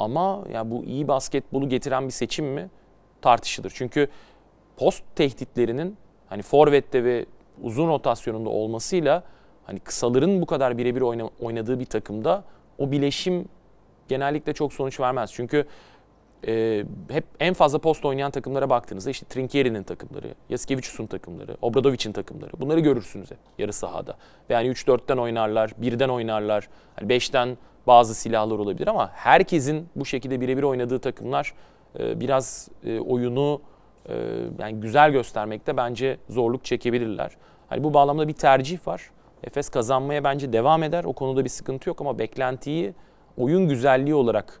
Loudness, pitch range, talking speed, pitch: -24 LUFS, 120-145 Hz, 135 wpm, 130 Hz